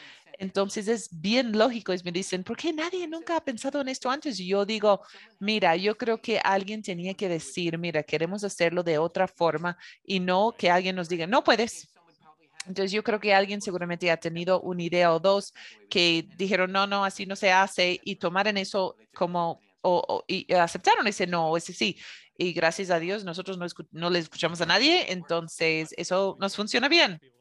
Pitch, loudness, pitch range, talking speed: 185 Hz, -26 LUFS, 175-205 Hz, 195 wpm